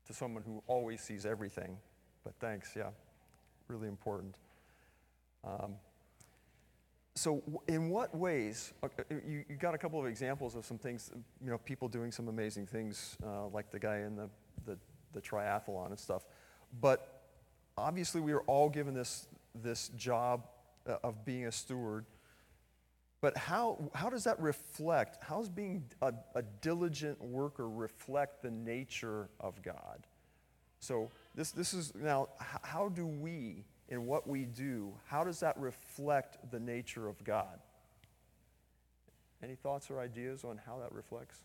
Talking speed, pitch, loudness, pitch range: 150 wpm, 120 Hz, -40 LUFS, 110-145 Hz